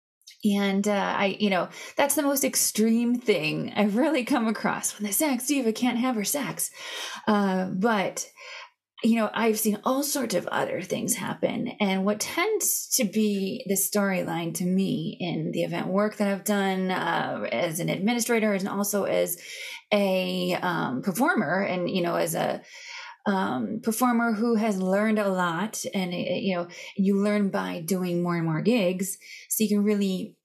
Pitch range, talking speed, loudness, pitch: 195-240 Hz, 175 wpm, -26 LUFS, 210 Hz